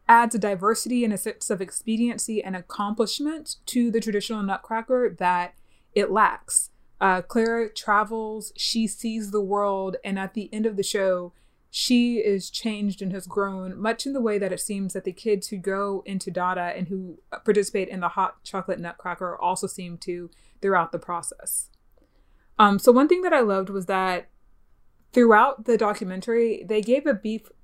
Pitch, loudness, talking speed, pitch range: 205 Hz, -24 LUFS, 175 wpm, 190-225 Hz